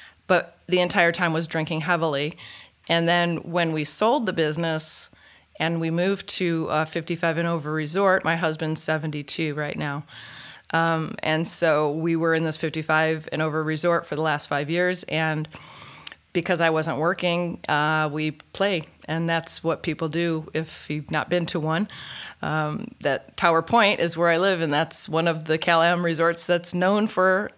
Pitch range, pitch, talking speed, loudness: 155-175 Hz, 165 Hz, 180 wpm, -23 LUFS